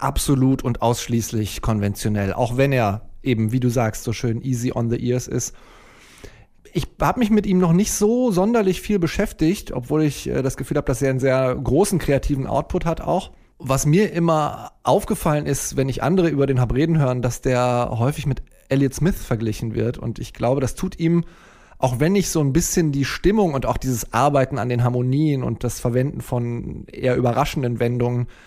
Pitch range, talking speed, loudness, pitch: 120-160 Hz, 190 wpm, -21 LUFS, 135 Hz